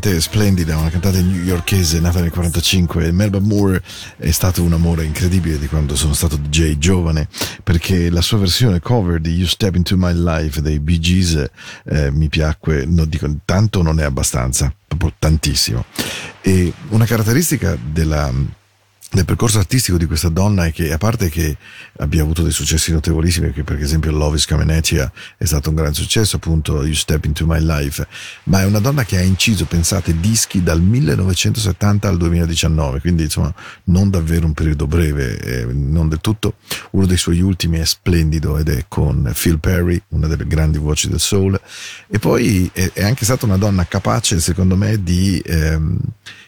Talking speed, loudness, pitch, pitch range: 175 wpm, -16 LUFS, 85 Hz, 80-95 Hz